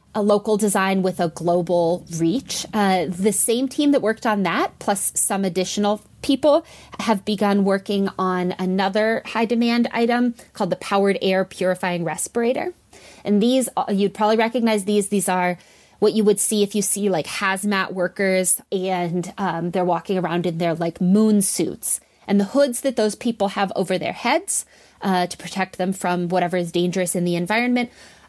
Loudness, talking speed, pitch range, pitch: -20 LUFS, 170 wpm, 180-215 Hz, 195 Hz